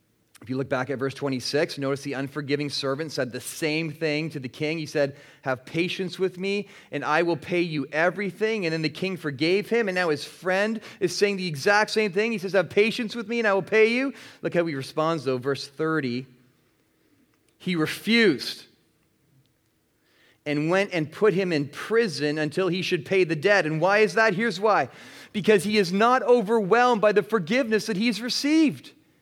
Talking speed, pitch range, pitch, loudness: 195 wpm, 150-210 Hz, 175 Hz, -24 LUFS